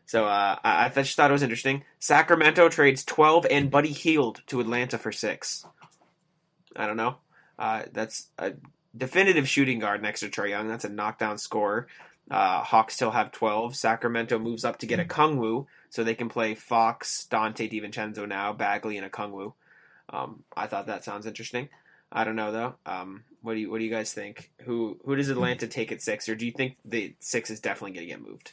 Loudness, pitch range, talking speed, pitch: -26 LUFS, 110-135 Hz, 210 wpm, 115 Hz